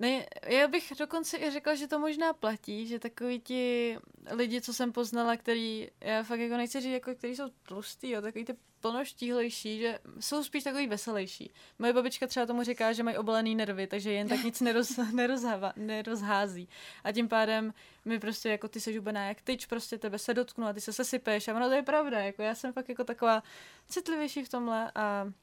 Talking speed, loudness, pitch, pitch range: 195 wpm, -33 LUFS, 235 Hz, 220-255 Hz